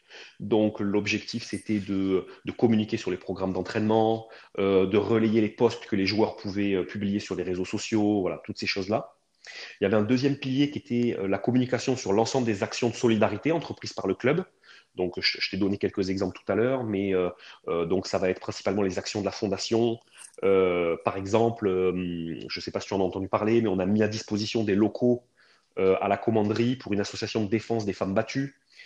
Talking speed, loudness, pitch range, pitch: 225 wpm, -27 LUFS, 95-115 Hz, 105 Hz